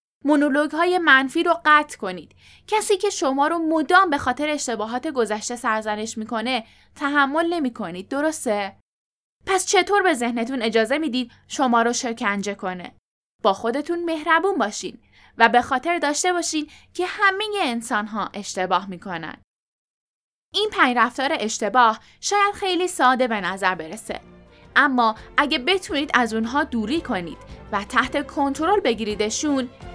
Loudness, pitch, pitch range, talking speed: -21 LUFS, 265 Hz, 225-325 Hz, 130 wpm